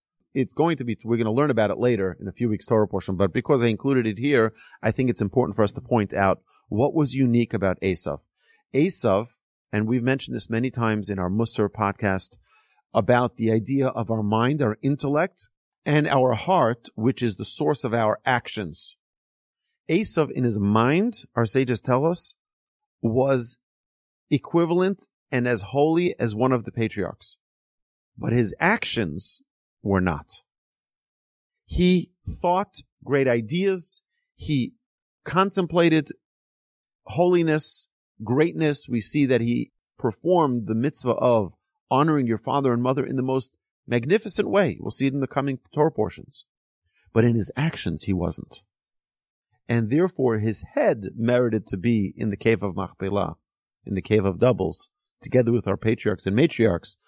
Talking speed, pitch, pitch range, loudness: 160 wpm, 120 Hz, 105-145 Hz, -23 LUFS